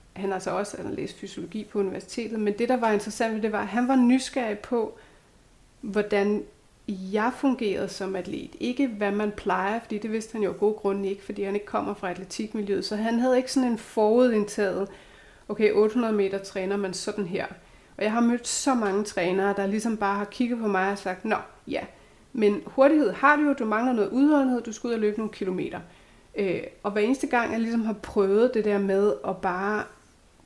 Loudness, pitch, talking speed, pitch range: -26 LUFS, 210 Hz, 210 wpm, 200-235 Hz